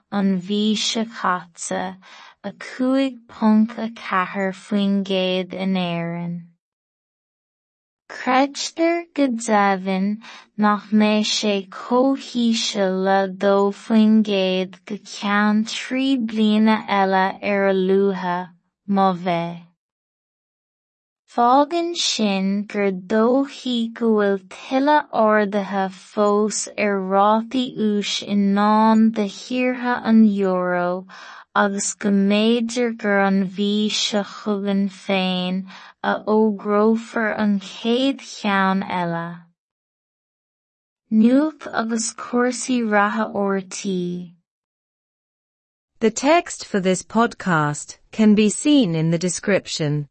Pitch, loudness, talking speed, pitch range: 205 Hz, -20 LUFS, 85 wpm, 190-225 Hz